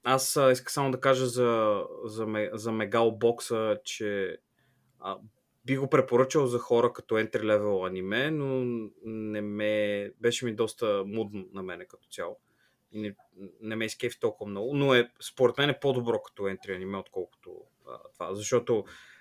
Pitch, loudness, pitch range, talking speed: 115 Hz, -29 LUFS, 105-130 Hz, 160 wpm